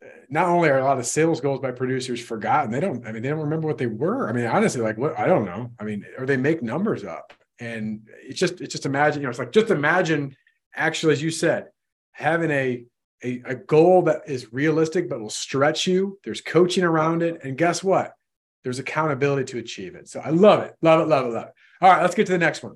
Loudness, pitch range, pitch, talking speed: -22 LUFS, 125-165 Hz, 150 Hz, 250 wpm